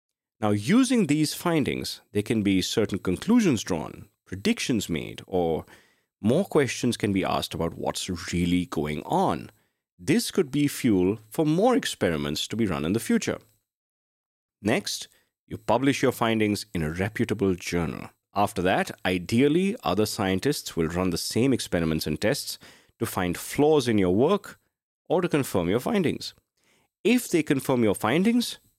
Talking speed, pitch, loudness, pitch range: 150 wpm, 110 Hz, -25 LUFS, 95-150 Hz